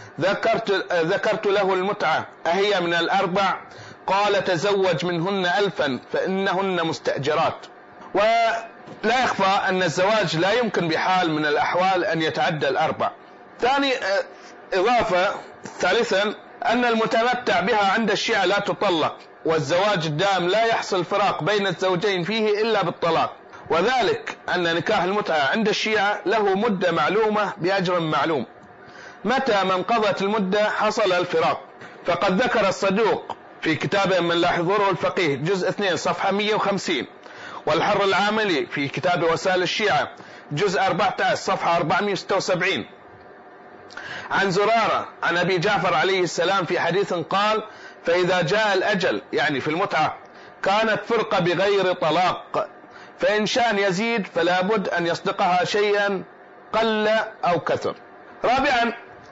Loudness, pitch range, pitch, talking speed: -21 LUFS, 180-215 Hz, 195 Hz, 115 wpm